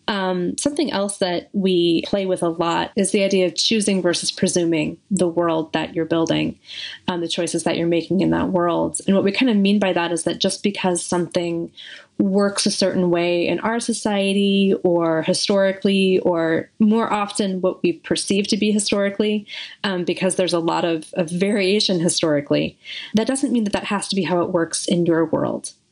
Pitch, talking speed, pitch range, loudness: 185 Hz, 195 wpm, 170-200 Hz, -20 LUFS